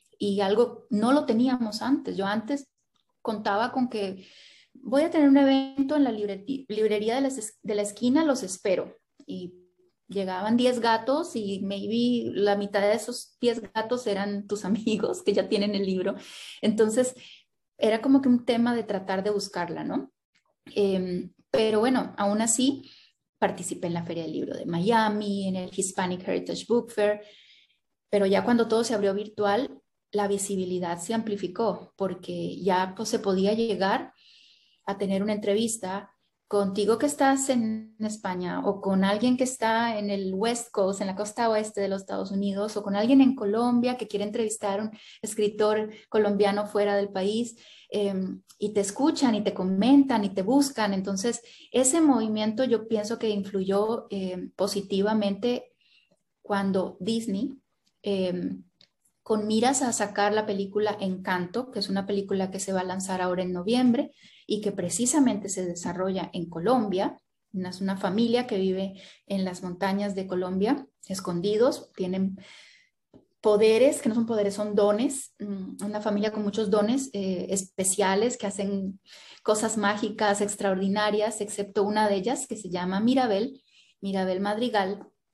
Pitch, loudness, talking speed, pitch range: 210 Hz, -26 LUFS, 155 wpm, 195-235 Hz